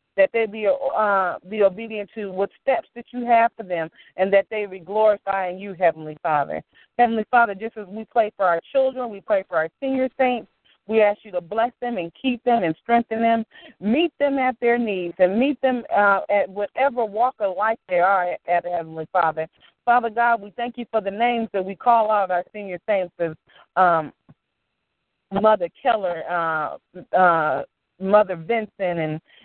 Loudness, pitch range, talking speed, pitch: -22 LUFS, 180-235 Hz, 185 wpm, 210 Hz